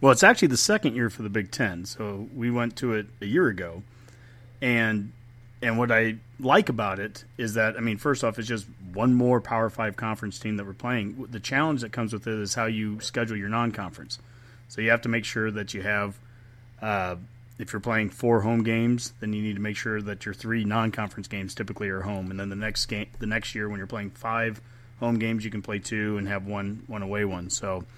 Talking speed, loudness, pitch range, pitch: 235 wpm, -27 LUFS, 105-120 Hz, 110 Hz